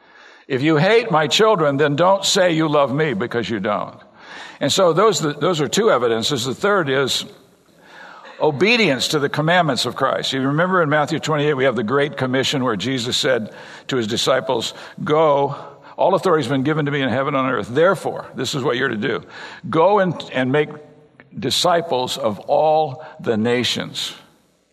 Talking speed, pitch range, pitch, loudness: 180 wpm, 135-160 Hz, 150 Hz, -18 LUFS